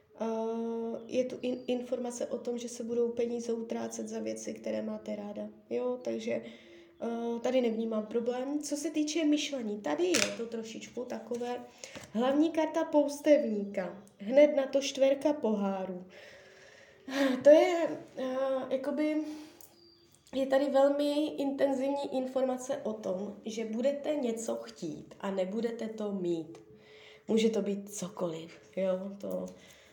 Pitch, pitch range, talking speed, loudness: 235 Hz, 185-275 Hz, 130 wpm, -32 LUFS